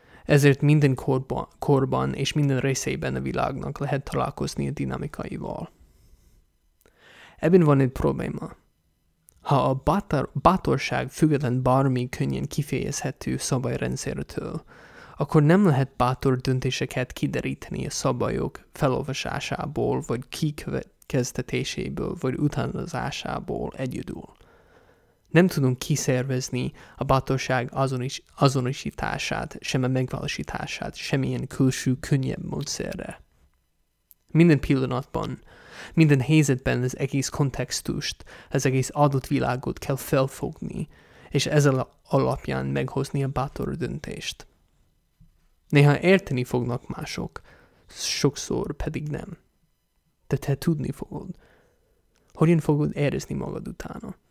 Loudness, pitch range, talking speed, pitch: -25 LUFS, 125-145 Hz, 100 wpm, 135 Hz